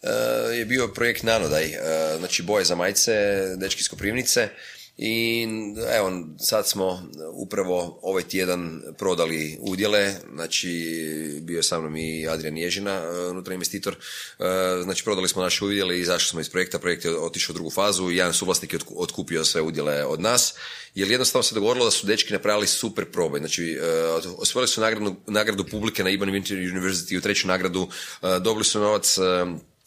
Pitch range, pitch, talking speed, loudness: 85-105 Hz, 95 Hz, 175 wpm, -23 LUFS